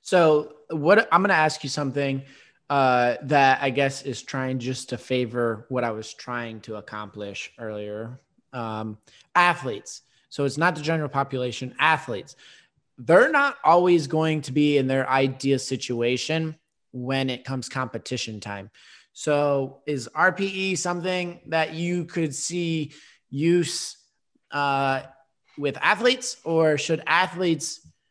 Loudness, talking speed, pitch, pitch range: -24 LUFS, 135 wpm, 140 Hz, 125-160 Hz